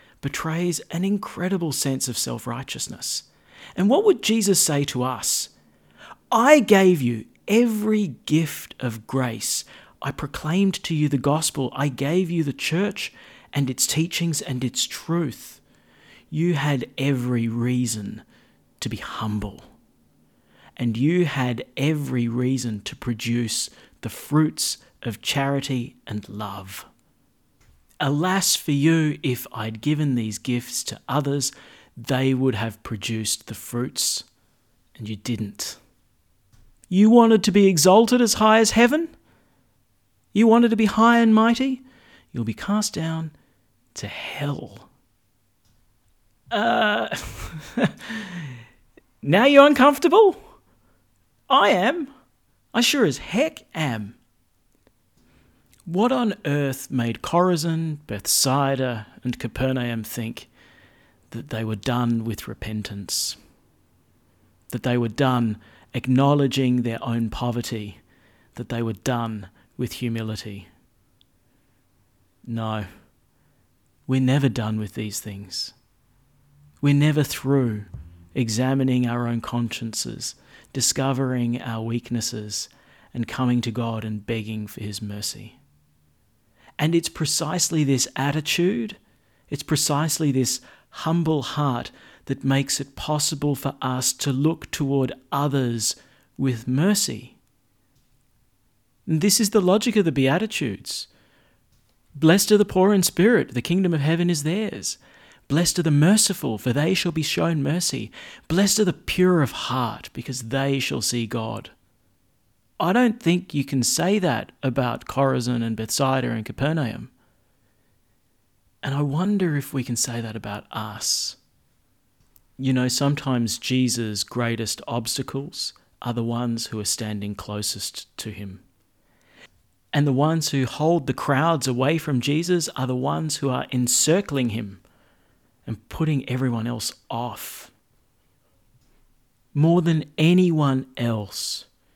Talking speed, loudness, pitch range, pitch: 125 wpm, -22 LUFS, 115-160 Hz, 130 Hz